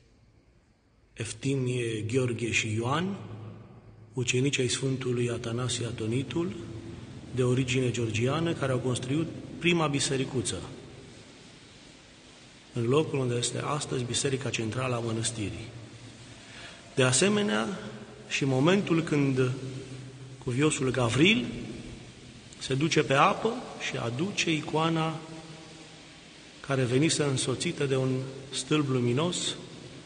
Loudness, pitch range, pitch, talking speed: -28 LUFS, 120-150 Hz, 130 Hz, 95 wpm